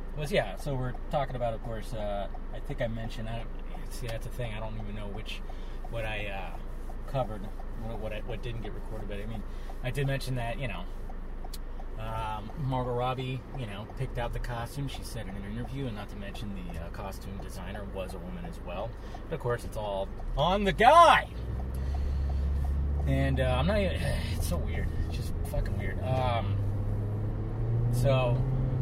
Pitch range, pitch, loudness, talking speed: 95-120 Hz, 105 Hz, -31 LUFS, 190 wpm